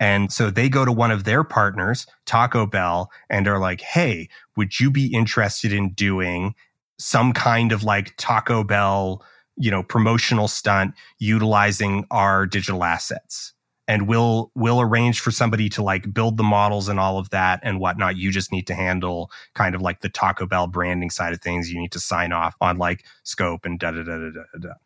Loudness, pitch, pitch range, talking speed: -21 LUFS, 100 Hz, 90-115 Hz, 200 wpm